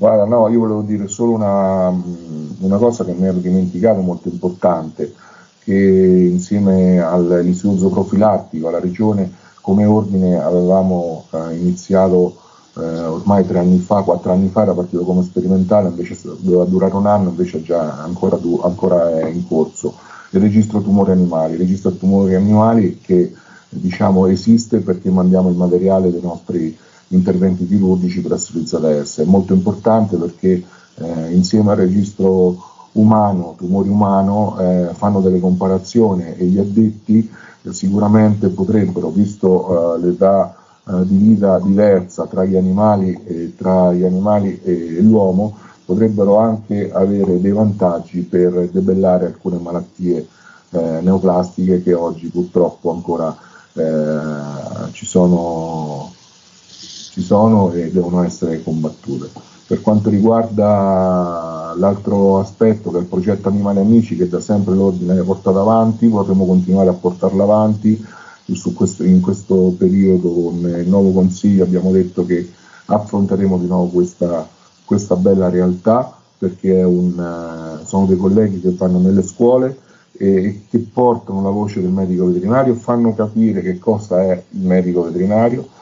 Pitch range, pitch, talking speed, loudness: 90-100 Hz, 95 Hz, 140 wpm, -15 LUFS